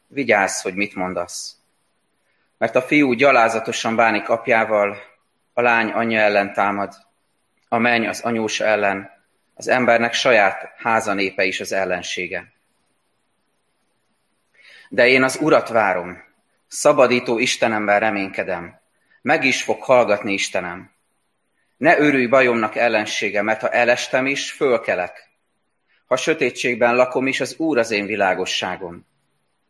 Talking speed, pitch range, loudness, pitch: 120 wpm, 100-120 Hz, -18 LUFS, 110 Hz